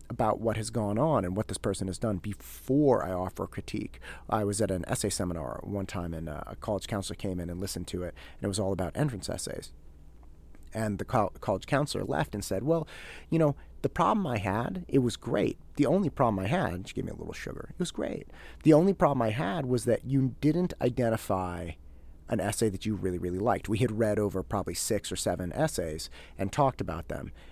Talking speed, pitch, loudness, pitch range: 220 wpm, 105 Hz, -30 LUFS, 90-125 Hz